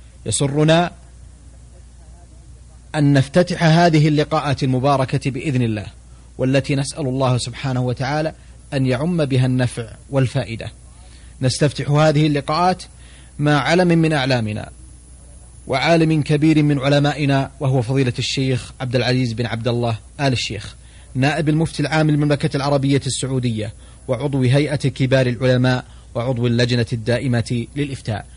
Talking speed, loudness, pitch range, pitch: 110 wpm, -18 LUFS, 115-145 Hz, 130 Hz